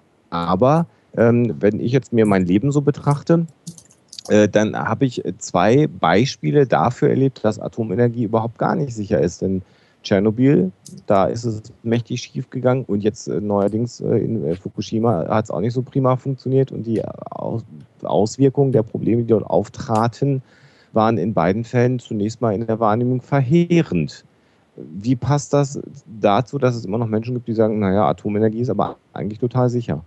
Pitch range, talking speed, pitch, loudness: 105-135 Hz, 160 wpm, 115 Hz, -19 LUFS